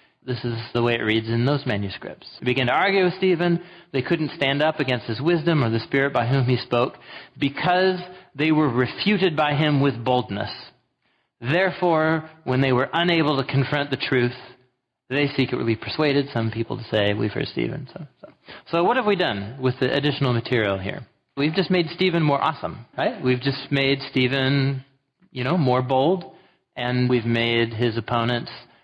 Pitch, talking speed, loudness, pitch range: 135 Hz, 185 wpm, -22 LUFS, 125-160 Hz